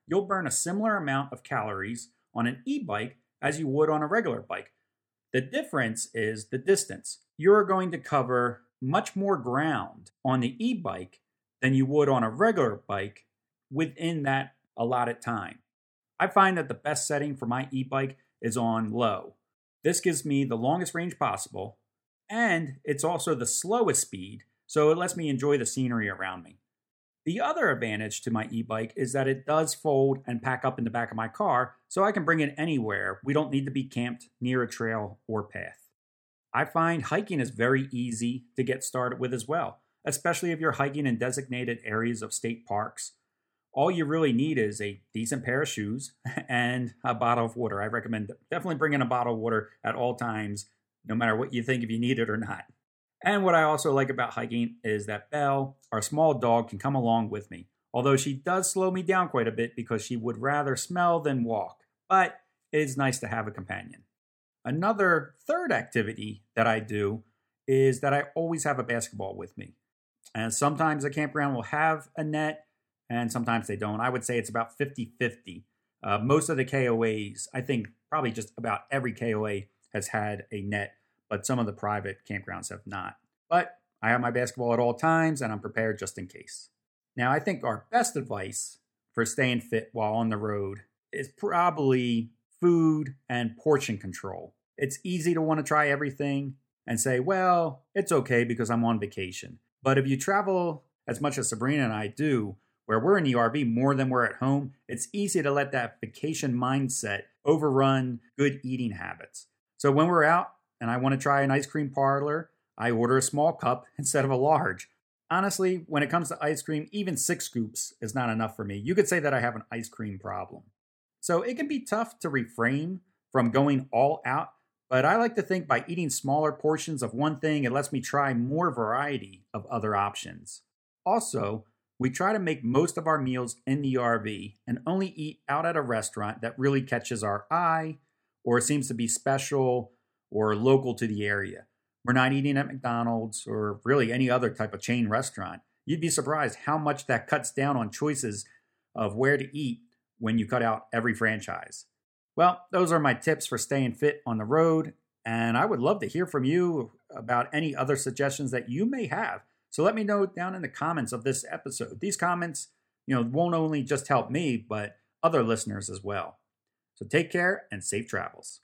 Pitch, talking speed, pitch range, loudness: 130 Hz, 200 wpm, 115-150 Hz, -28 LUFS